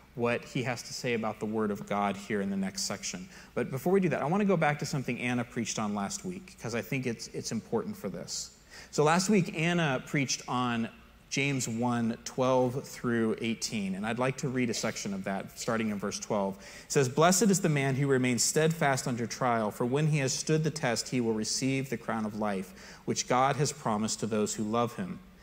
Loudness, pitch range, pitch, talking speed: -30 LUFS, 115-155 Hz, 130 Hz, 230 wpm